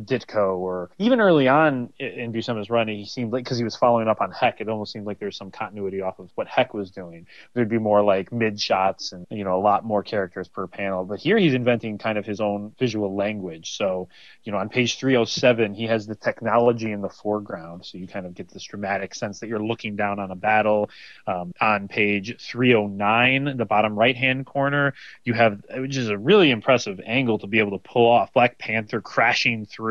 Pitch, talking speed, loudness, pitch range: 110 Hz, 220 wpm, -22 LUFS, 100-120 Hz